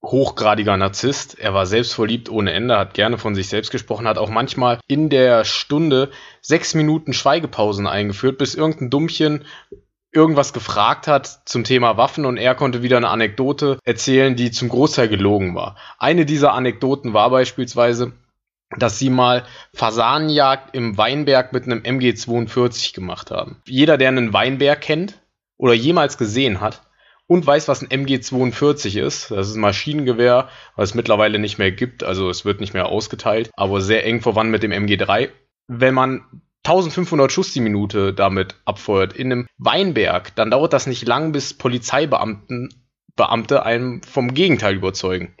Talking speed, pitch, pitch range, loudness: 160 wpm, 125 Hz, 110-135 Hz, -18 LUFS